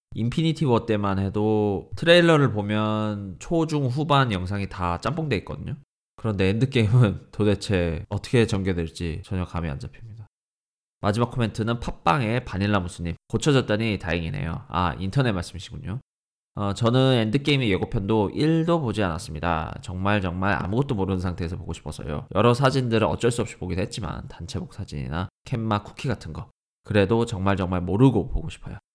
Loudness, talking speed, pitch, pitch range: -24 LUFS, 375 characters per minute, 105 Hz, 95-120 Hz